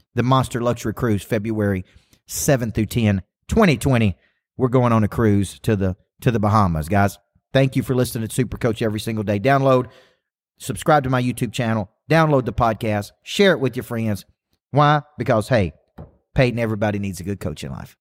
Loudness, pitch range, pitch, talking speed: -20 LUFS, 105-130 Hz, 115 Hz, 185 wpm